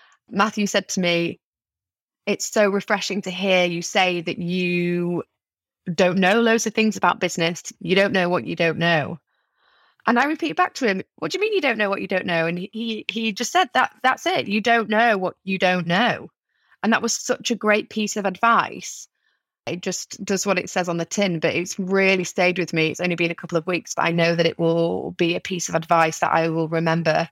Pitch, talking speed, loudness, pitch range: 185 Hz, 235 wpm, -21 LUFS, 170-220 Hz